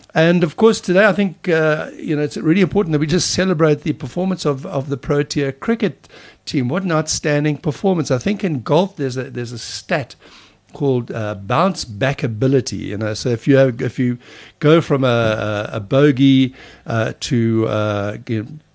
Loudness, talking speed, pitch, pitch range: -18 LUFS, 200 wpm, 140 Hz, 120-165 Hz